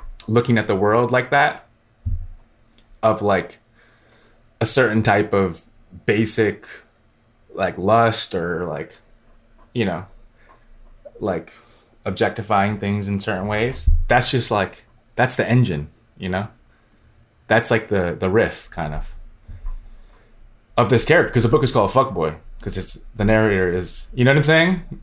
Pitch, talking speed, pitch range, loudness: 110 Hz, 140 wpm, 100-115 Hz, -19 LUFS